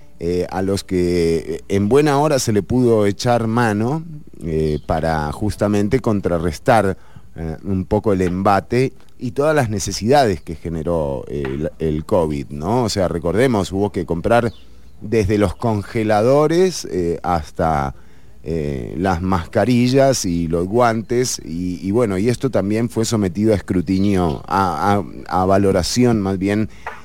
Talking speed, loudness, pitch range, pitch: 145 wpm, -18 LUFS, 85-115 Hz, 100 Hz